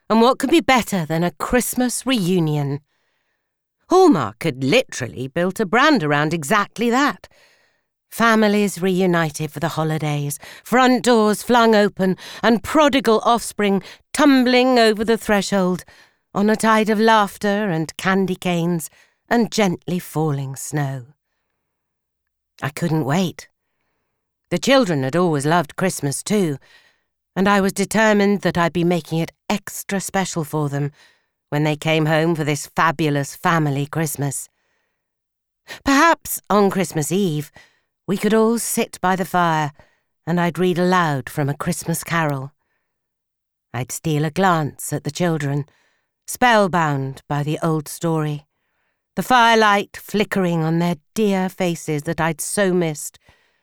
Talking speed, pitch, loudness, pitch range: 135 wpm, 180 Hz, -19 LUFS, 155-210 Hz